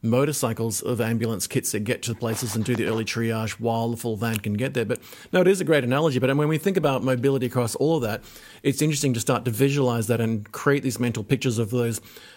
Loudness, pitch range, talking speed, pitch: -24 LUFS, 115-135 Hz, 250 wpm, 125 Hz